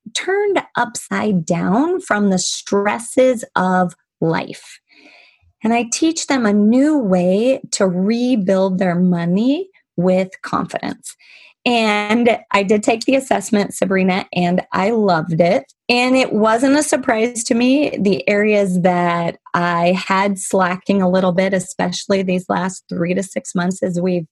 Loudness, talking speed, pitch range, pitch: -17 LUFS, 140 wpm, 185-245 Hz, 200 Hz